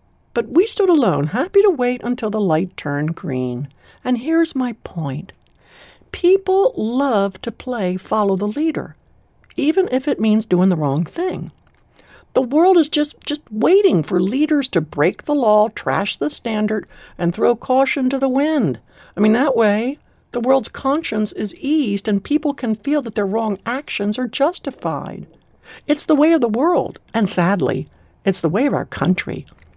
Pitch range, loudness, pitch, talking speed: 200-295 Hz, -18 LUFS, 240 Hz, 170 wpm